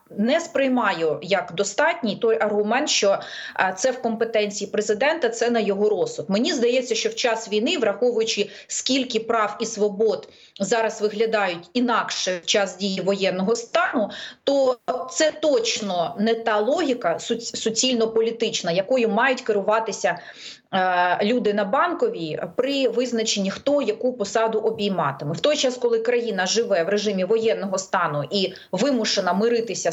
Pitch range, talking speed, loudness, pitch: 200-245 Hz, 130 wpm, -22 LUFS, 220 Hz